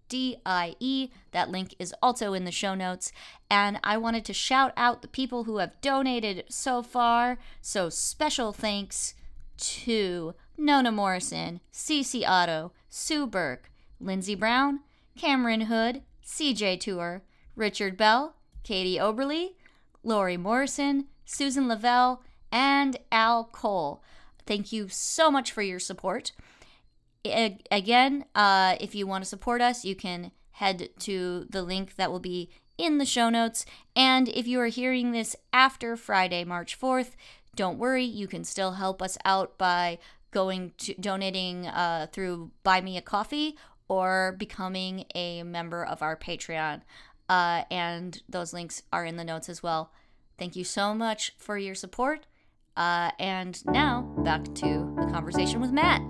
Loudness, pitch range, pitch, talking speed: -28 LUFS, 180-245 Hz, 205 Hz, 150 wpm